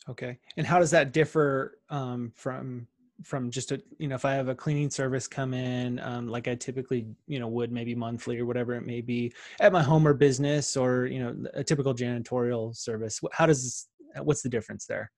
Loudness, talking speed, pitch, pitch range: -28 LUFS, 215 wpm, 130 Hz, 120-145 Hz